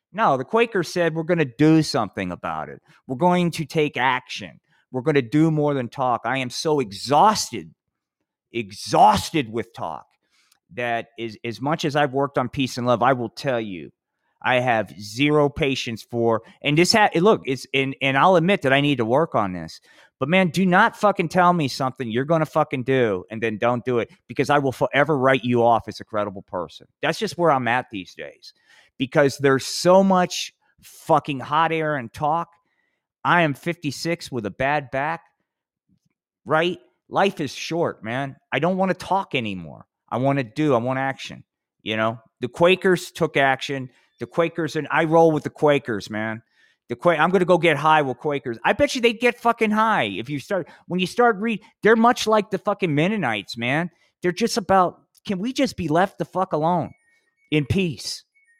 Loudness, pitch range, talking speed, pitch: -21 LUFS, 125-180 Hz, 200 wpm, 150 Hz